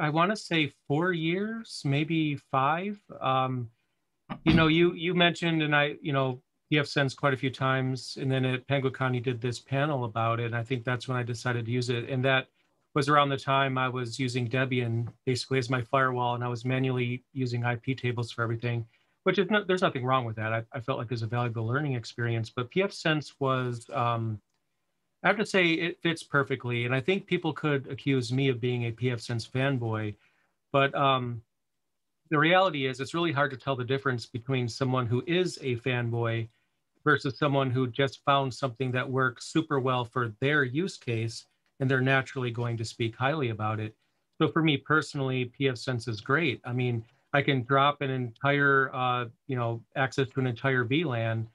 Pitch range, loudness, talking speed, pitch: 120-145 Hz, -28 LUFS, 200 wpm, 130 Hz